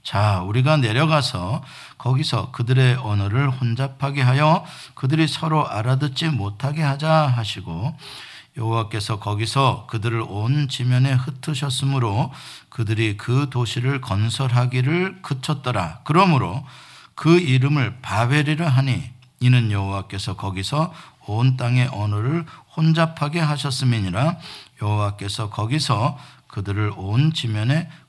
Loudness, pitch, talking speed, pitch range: -21 LUFS, 130 Hz, 280 characters per minute, 115-145 Hz